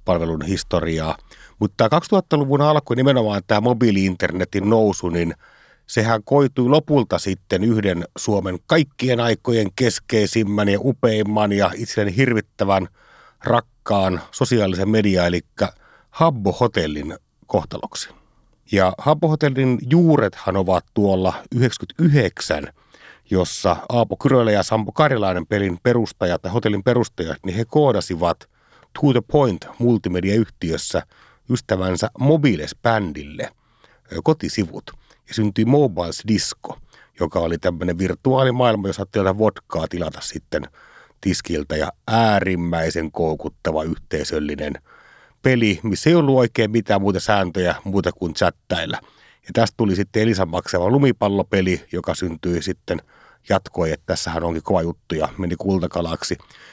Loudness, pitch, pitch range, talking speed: -20 LUFS, 105 Hz, 90-120 Hz, 115 wpm